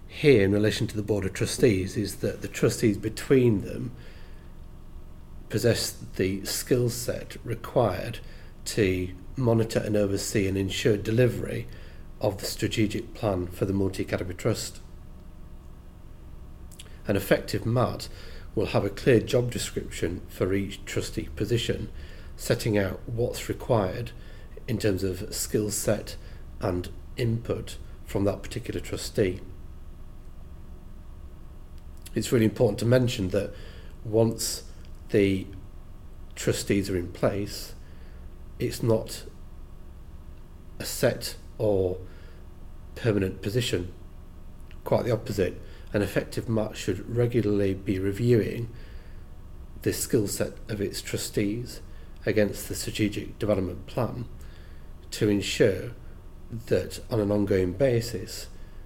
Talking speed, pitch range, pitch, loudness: 110 wpm, 85-110 Hz, 95 Hz, -27 LUFS